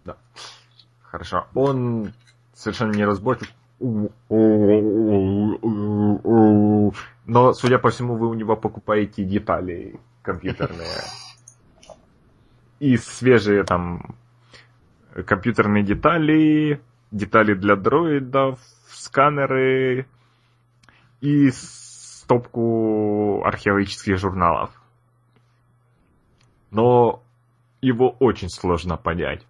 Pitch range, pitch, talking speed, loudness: 105-125 Hz, 120 Hz, 70 wpm, -20 LUFS